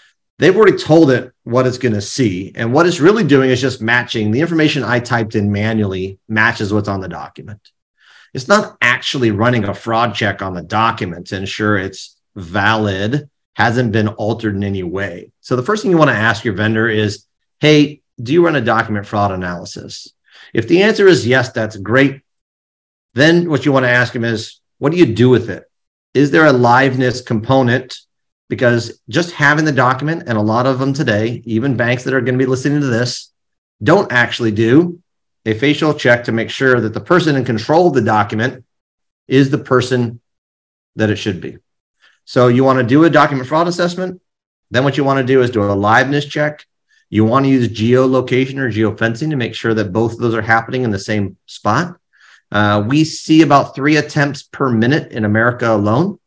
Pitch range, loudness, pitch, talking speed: 110-140 Hz, -14 LUFS, 120 Hz, 200 wpm